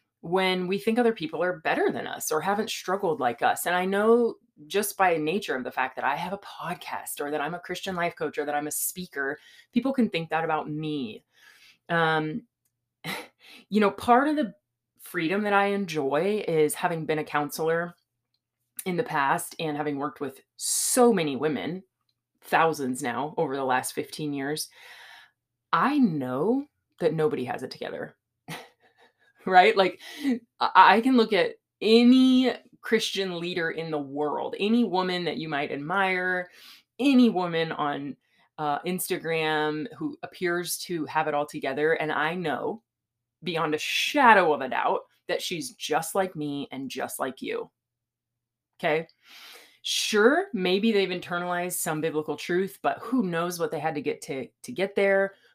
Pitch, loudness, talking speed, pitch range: 170 Hz, -26 LUFS, 165 wpm, 150-200 Hz